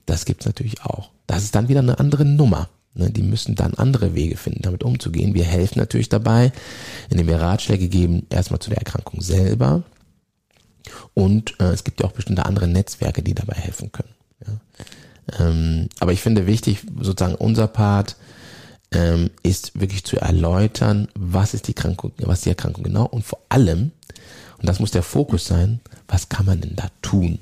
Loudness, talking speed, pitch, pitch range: -20 LUFS, 185 wpm, 105 Hz, 95-120 Hz